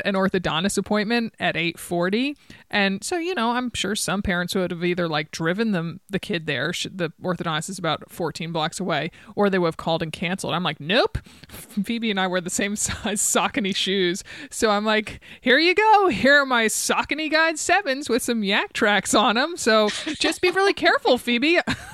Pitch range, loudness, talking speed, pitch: 180-245 Hz, -22 LUFS, 195 wpm, 205 Hz